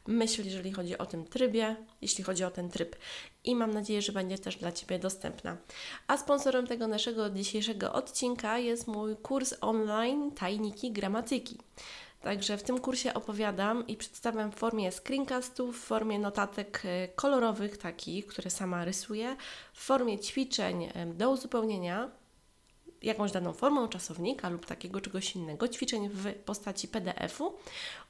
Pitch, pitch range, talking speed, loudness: 215 Hz, 190-245 Hz, 145 wpm, -34 LUFS